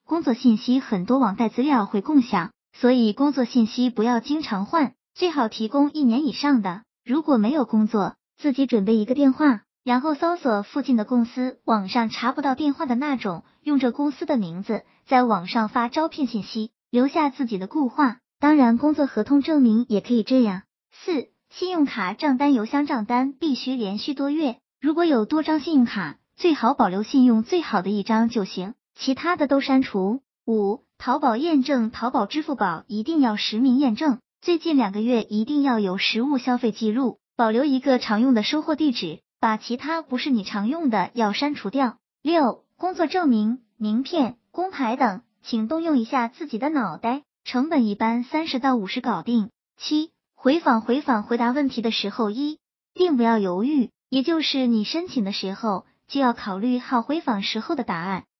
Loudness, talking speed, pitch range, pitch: -22 LUFS, 275 characters per minute, 220-285 Hz, 250 Hz